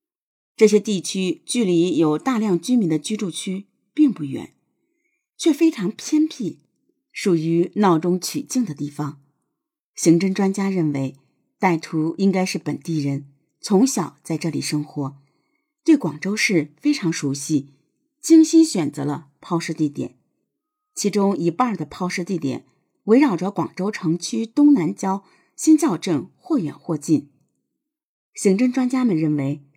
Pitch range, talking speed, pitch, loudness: 155-260 Hz, 210 characters per minute, 190 Hz, -21 LUFS